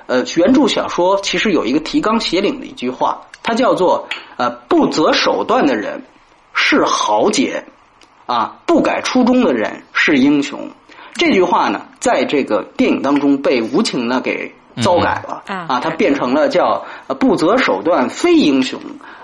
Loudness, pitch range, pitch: -15 LUFS, 215-305 Hz, 290 Hz